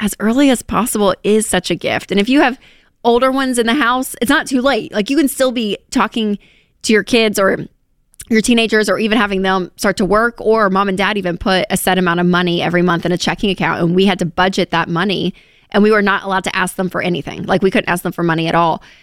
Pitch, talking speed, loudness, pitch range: 200 Hz, 260 wpm, -15 LUFS, 180-225 Hz